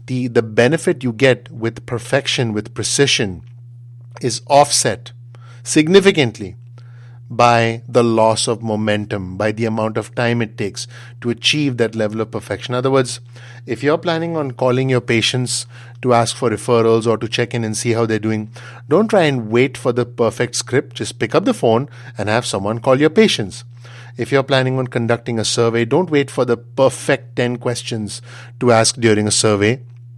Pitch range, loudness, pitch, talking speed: 115-125 Hz, -17 LUFS, 120 Hz, 180 wpm